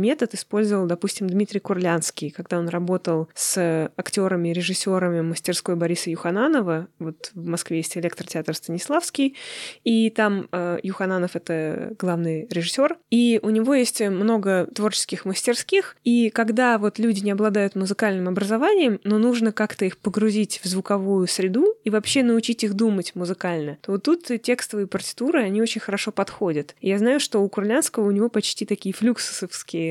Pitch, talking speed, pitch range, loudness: 200 Hz, 150 wpm, 180-225 Hz, -23 LUFS